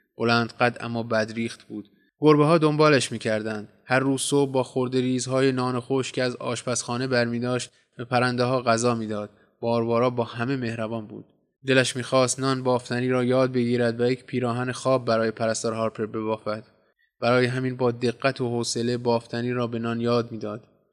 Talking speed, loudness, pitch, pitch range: 175 wpm, -24 LUFS, 120 Hz, 115-130 Hz